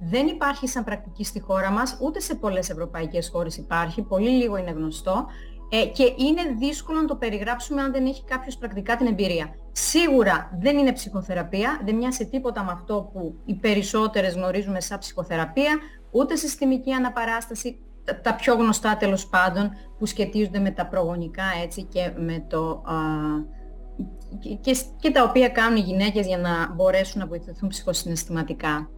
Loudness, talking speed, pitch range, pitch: -24 LUFS, 165 wpm, 180-250 Hz, 205 Hz